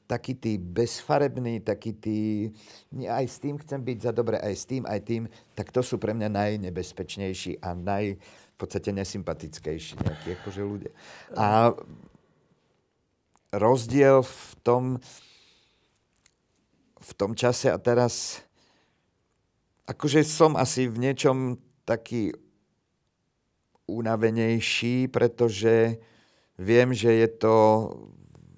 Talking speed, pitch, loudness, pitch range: 105 wpm, 115 Hz, -26 LUFS, 105-125 Hz